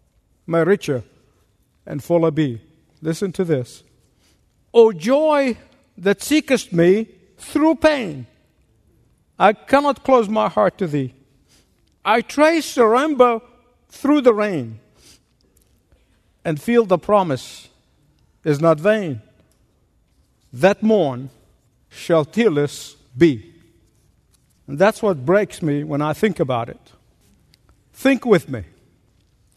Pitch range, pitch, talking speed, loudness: 135-225 Hz, 170 Hz, 110 wpm, -18 LUFS